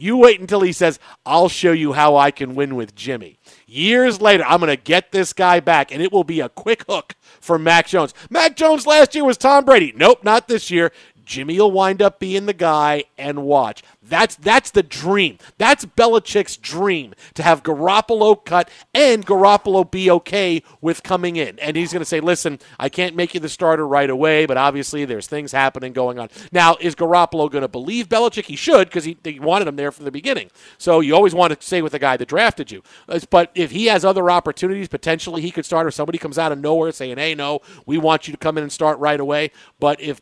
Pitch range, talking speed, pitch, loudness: 150-195 Hz, 225 wpm, 170 Hz, -16 LUFS